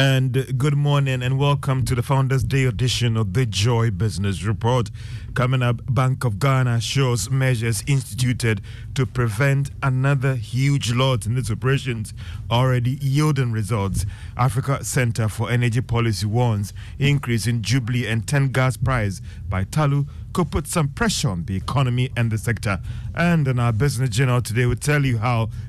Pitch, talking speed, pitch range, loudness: 125 Hz, 165 wpm, 115-135 Hz, -21 LUFS